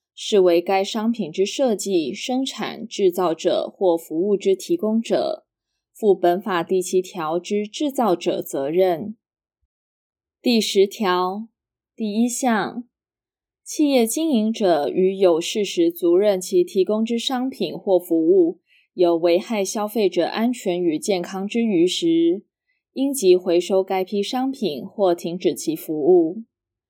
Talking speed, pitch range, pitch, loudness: 190 characters per minute, 180-245 Hz, 200 Hz, -21 LUFS